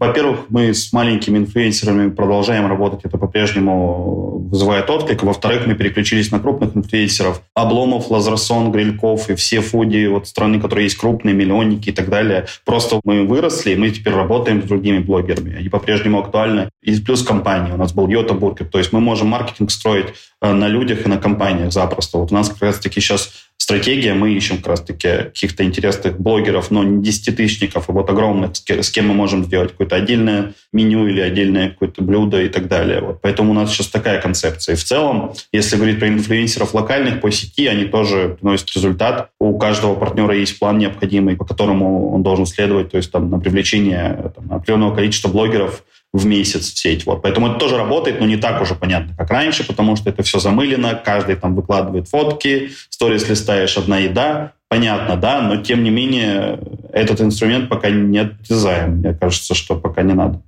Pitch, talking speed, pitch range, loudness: 105 Hz, 185 wpm, 95-110 Hz, -16 LUFS